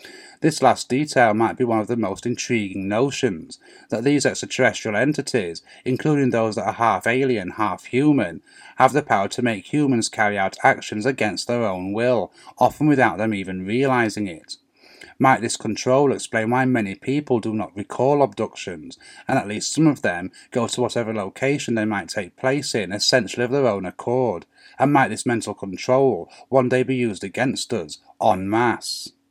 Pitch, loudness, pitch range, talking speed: 120 Hz, -21 LUFS, 105-130 Hz, 175 wpm